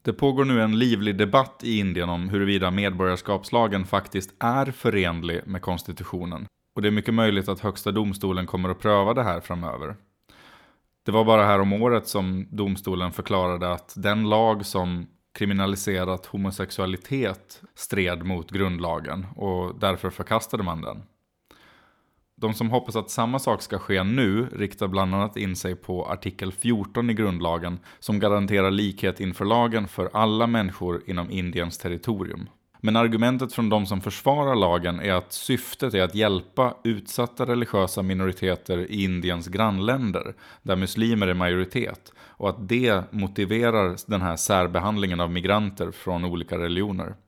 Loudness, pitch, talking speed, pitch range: -25 LUFS, 100 Hz, 150 wpm, 90-110 Hz